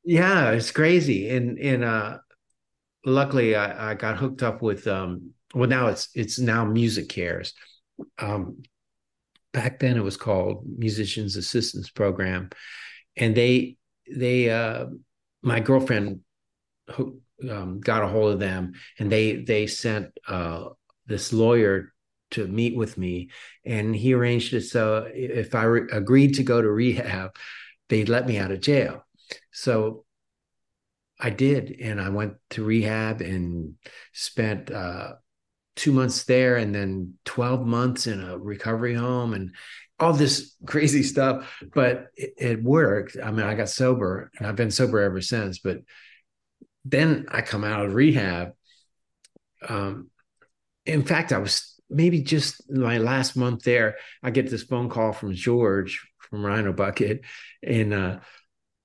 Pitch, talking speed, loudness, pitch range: 115 Hz, 150 wpm, -24 LUFS, 105-130 Hz